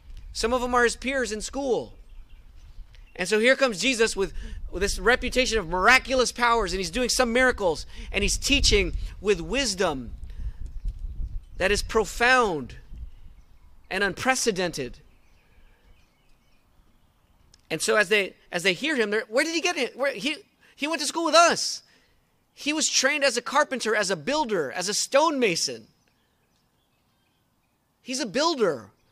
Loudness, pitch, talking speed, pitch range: -24 LUFS, 220 Hz, 150 wpm, 160-260 Hz